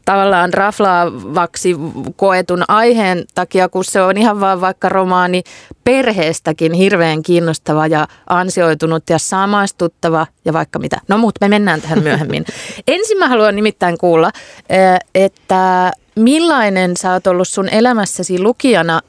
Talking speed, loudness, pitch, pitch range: 130 wpm, -13 LUFS, 185 Hz, 170-205 Hz